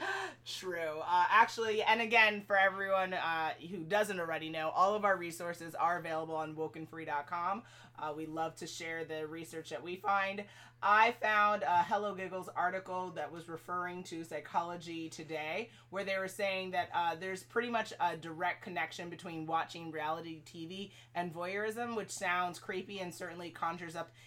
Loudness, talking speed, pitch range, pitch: -35 LUFS, 165 wpm, 160-195 Hz, 175 Hz